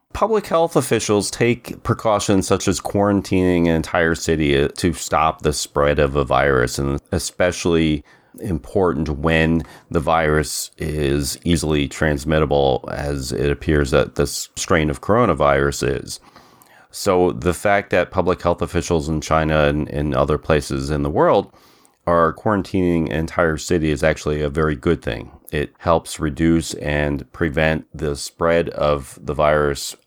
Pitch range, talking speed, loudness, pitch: 75-85 Hz, 145 wpm, -19 LUFS, 80 Hz